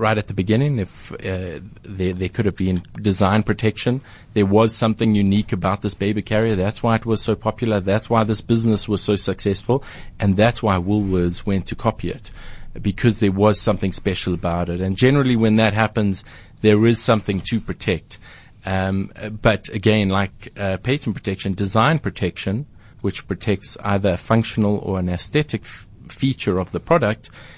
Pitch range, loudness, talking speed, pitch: 95-110 Hz, -20 LUFS, 175 wpm, 105 Hz